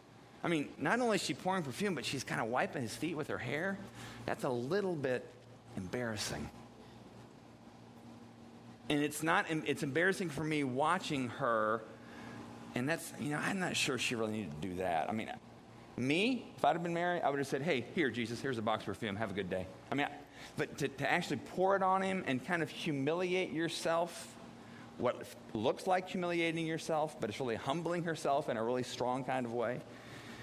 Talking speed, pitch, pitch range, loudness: 195 wpm, 145 Hz, 120-175 Hz, -36 LUFS